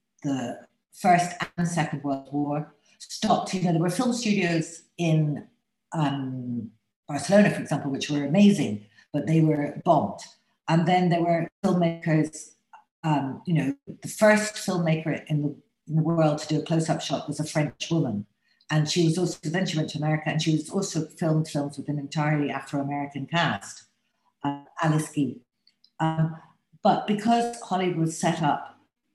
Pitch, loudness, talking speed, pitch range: 160 Hz, -26 LUFS, 165 wpm, 145-180 Hz